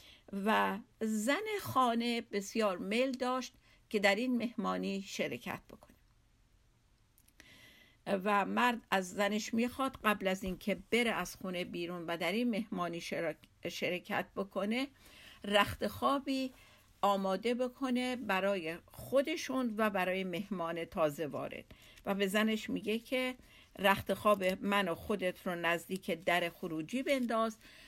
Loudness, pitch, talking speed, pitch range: -35 LUFS, 205 Hz, 120 wpm, 185-240 Hz